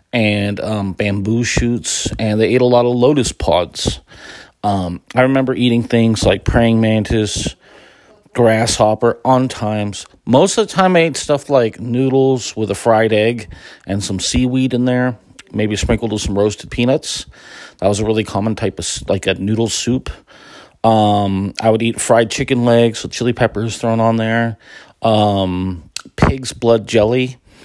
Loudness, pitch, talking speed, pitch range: -15 LUFS, 110 Hz, 165 wpm, 105-120 Hz